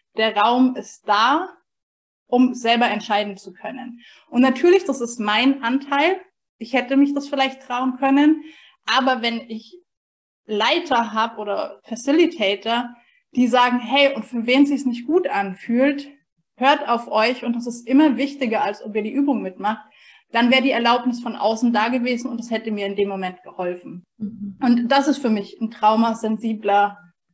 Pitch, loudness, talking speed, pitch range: 240 Hz, -20 LUFS, 170 wpm, 215-270 Hz